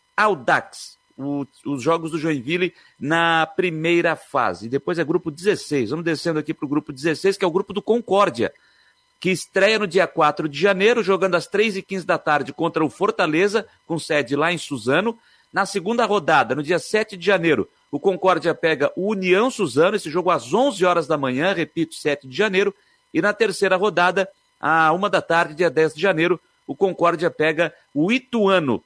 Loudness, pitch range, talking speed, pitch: -20 LUFS, 160-195 Hz, 190 wpm, 175 Hz